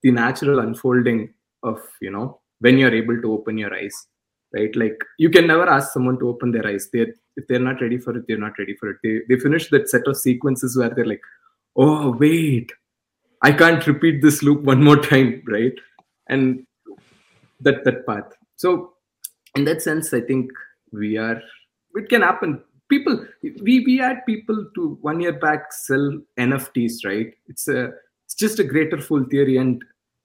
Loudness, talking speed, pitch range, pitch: -19 LUFS, 185 wpm, 120-155 Hz, 135 Hz